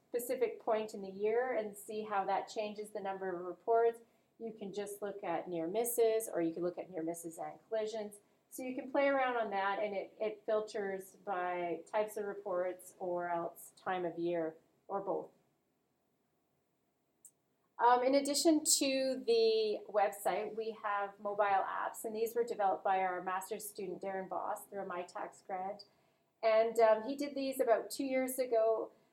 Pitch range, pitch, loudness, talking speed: 190-230 Hz, 210 Hz, -36 LUFS, 175 wpm